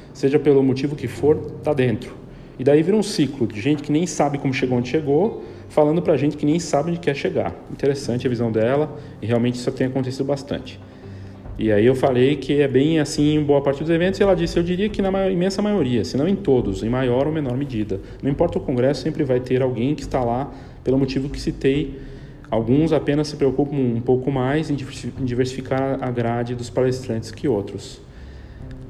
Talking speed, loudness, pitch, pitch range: 210 wpm, -21 LUFS, 135 Hz, 125-150 Hz